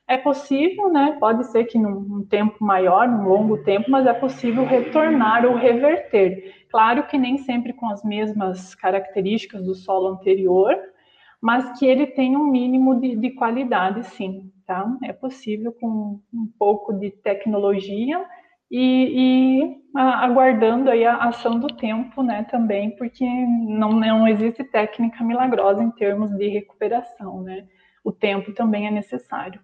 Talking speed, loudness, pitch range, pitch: 150 wpm, -20 LUFS, 205-255 Hz, 230 Hz